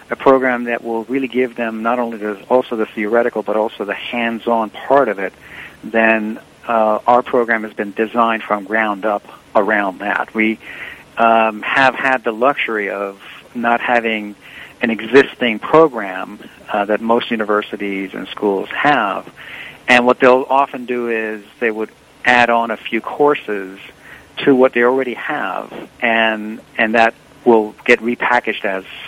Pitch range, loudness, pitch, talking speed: 110-120 Hz, -16 LUFS, 115 Hz, 155 wpm